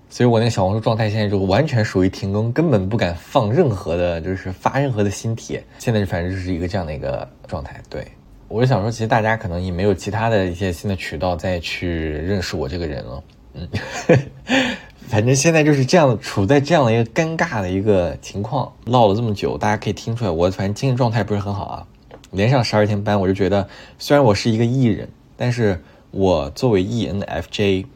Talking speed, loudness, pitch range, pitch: 340 characters per minute, -19 LUFS, 95-120 Hz, 105 Hz